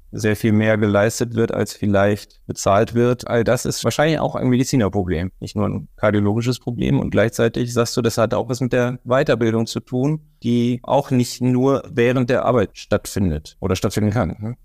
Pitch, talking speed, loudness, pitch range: 115 Hz, 190 wpm, -19 LUFS, 105-125 Hz